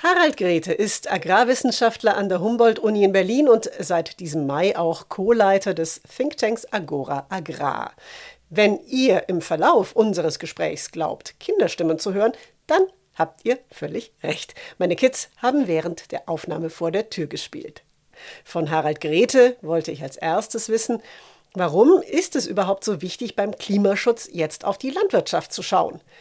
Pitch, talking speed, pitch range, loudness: 200 Hz, 150 wpm, 165-245 Hz, -21 LUFS